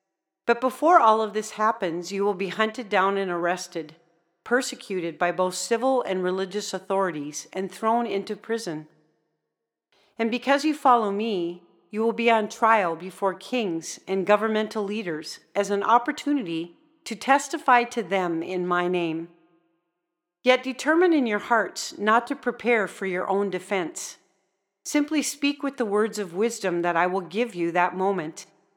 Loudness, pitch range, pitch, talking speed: -24 LUFS, 175-235 Hz, 200 Hz, 155 wpm